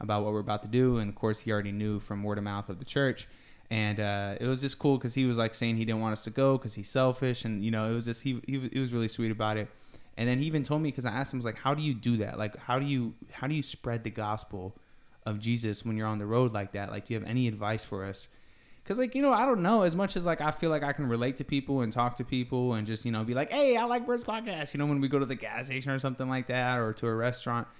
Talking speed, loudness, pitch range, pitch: 320 wpm, -31 LUFS, 110-135 Hz, 120 Hz